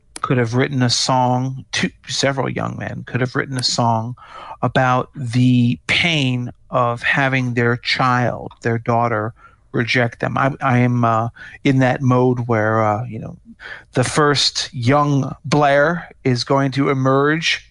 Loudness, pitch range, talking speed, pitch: -18 LUFS, 120-140 Hz, 150 wpm, 125 Hz